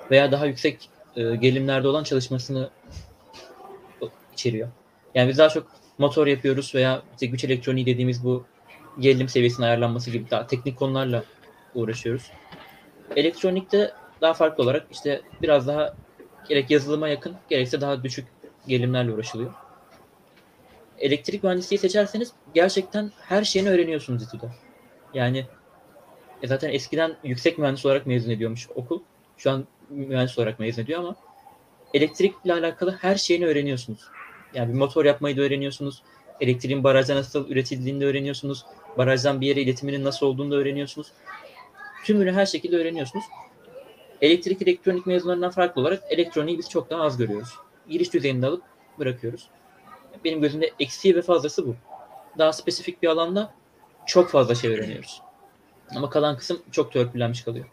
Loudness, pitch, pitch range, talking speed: -24 LUFS, 140 Hz, 130-170 Hz, 135 wpm